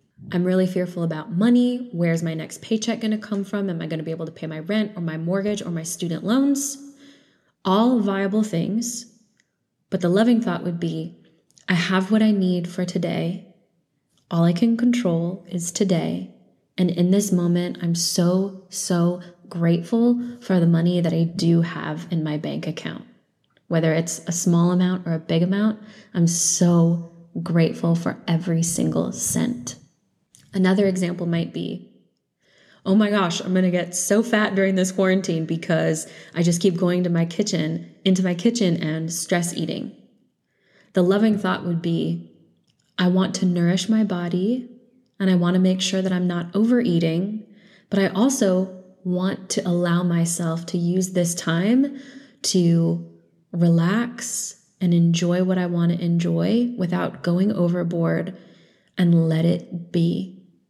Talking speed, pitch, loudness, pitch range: 165 wpm, 180 Hz, -22 LUFS, 170-200 Hz